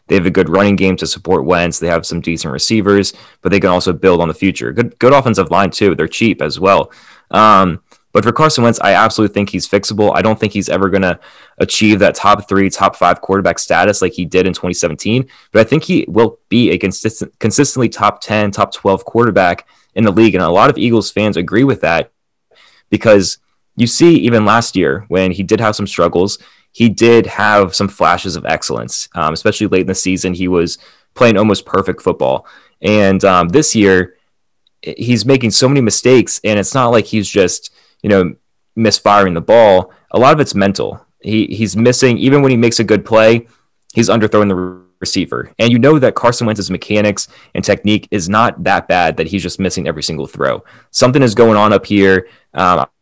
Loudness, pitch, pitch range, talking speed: -12 LUFS, 100 Hz, 95-115 Hz, 210 wpm